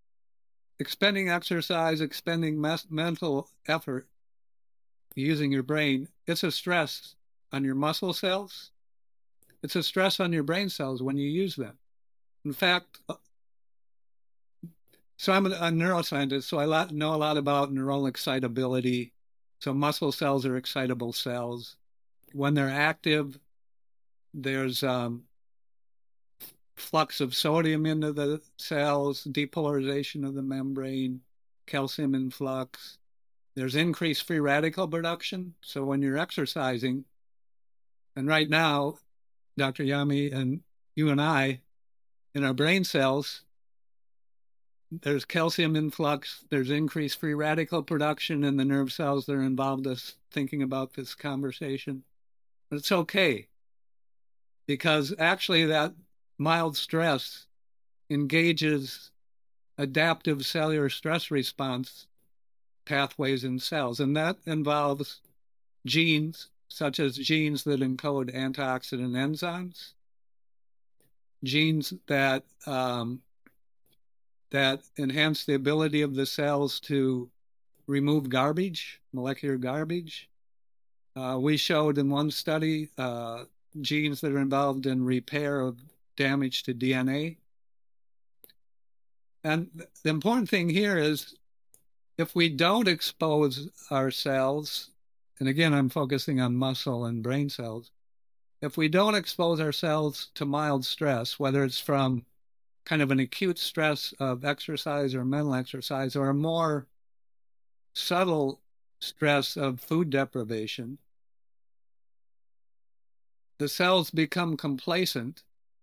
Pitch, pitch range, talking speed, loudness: 140 Hz, 130-155 Hz, 115 wpm, -28 LUFS